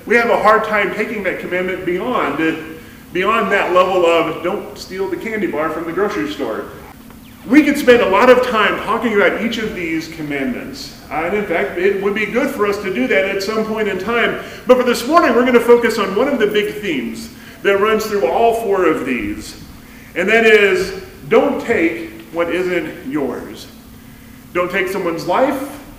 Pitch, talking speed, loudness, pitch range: 205 Hz, 195 wpm, -16 LUFS, 180-235 Hz